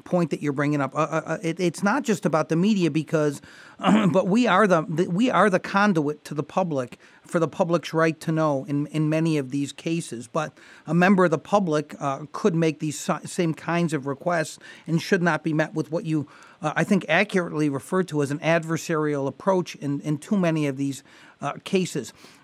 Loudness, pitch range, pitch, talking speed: -24 LUFS, 150-180 Hz, 160 Hz, 215 wpm